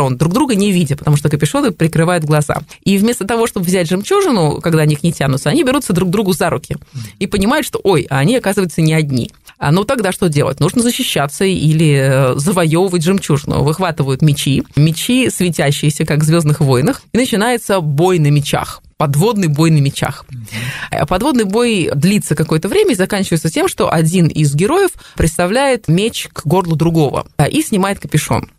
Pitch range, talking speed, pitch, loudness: 150-200 Hz, 170 wpm, 170 Hz, -14 LUFS